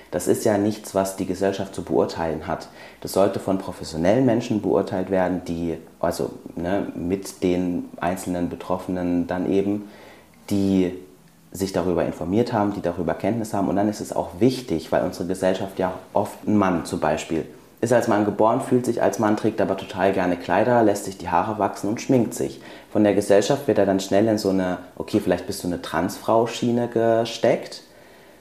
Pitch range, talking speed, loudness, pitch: 90-105 Hz, 185 wpm, -23 LUFS, 95 Hz